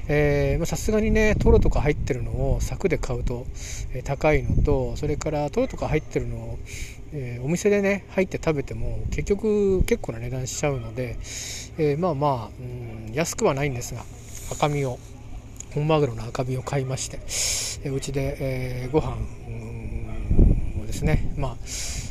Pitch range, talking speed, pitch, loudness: 115-150 Hz, 305 characters per minute, 130 Hz, -25 LUFS